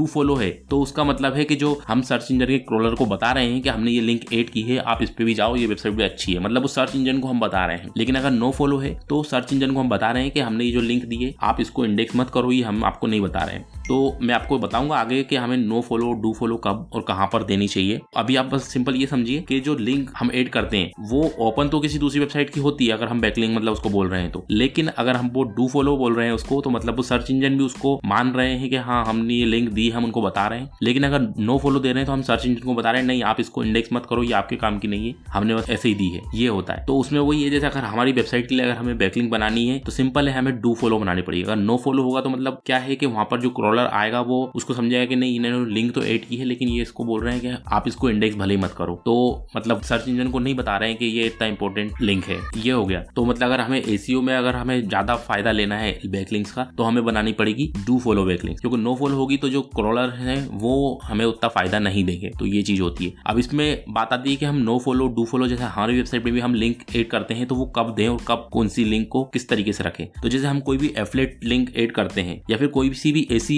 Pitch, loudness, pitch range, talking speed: 120 Hz, -21 LUFS, 110-130 Hz, 240 wpm